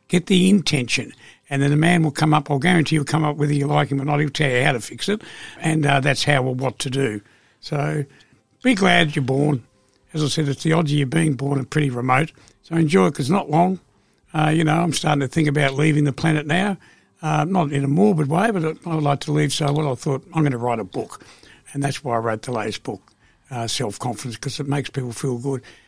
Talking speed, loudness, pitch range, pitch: 260 wpm, -20 LUFS, 130-160 Hz, 145 Hz